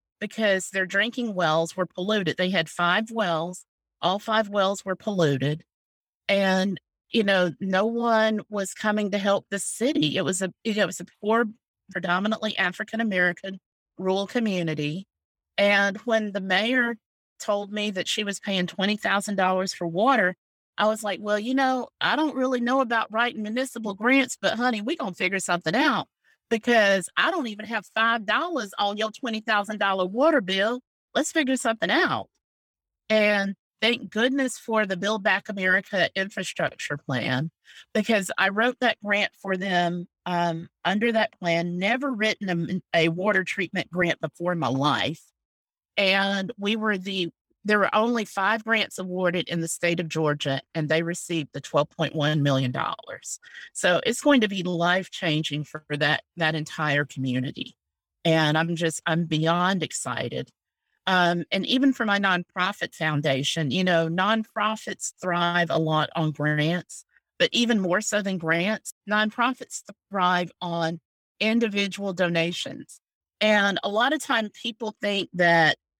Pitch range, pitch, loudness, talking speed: 170-220 Hz, 195 Hz, -24 LUFS, 155 wpm